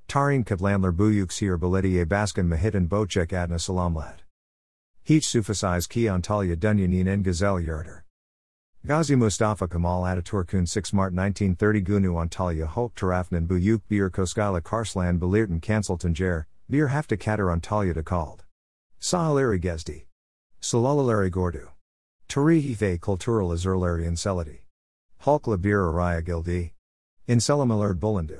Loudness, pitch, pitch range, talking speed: -25 LUFS, 95 Hz, 85-105 Hz, 125 wpm